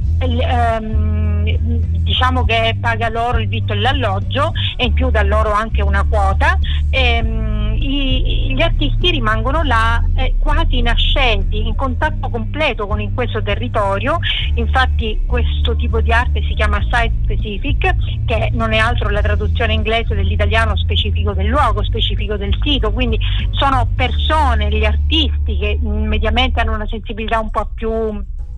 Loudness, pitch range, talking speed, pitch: -17 LUFS, 75-105 Hz, 135 wpm, 85 Hz